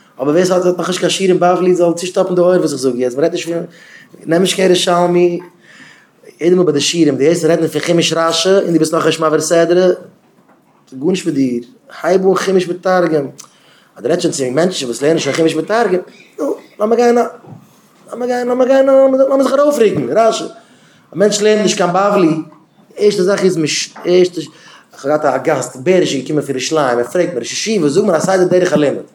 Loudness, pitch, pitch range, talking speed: -13 LUFS, 175 Hz, 160-190 Hz, 150 wpm